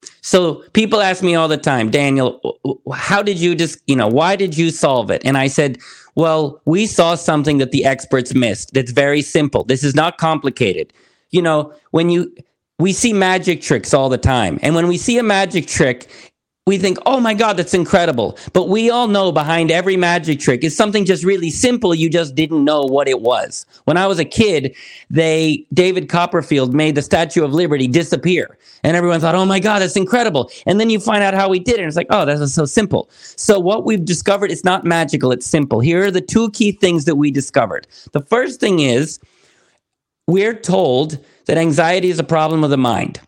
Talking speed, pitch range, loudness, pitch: 210 wpm, 150-190 Hz, -15 LUFS, 165 Hz